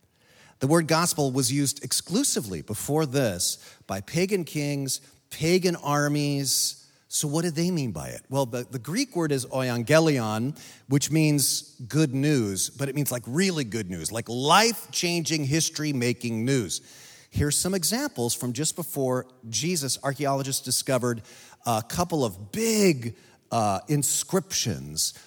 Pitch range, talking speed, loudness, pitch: 125-160 Hz, 135 wpm, -25 LUFS, 140 Hz